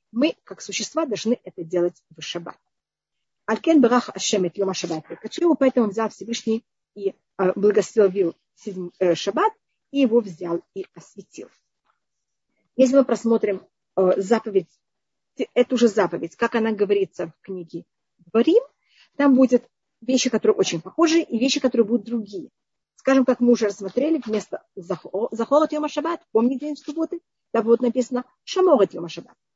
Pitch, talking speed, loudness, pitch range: 230 Hz, 140 wpm, -22 LUFS, 190-260 Hz